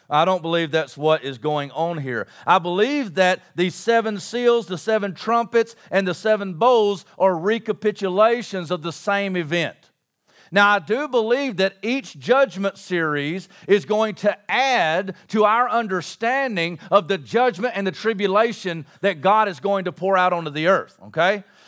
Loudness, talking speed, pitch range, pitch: -21 LUFS, 165 wpm, 180-220 Hz, 195 Hz